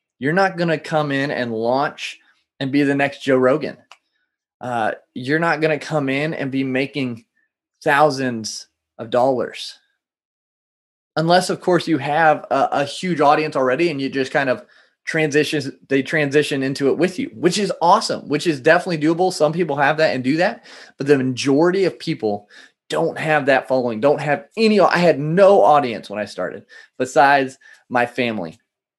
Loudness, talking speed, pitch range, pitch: -18 LUFS, 175 wpm, 135-165 Hz, 150 Hz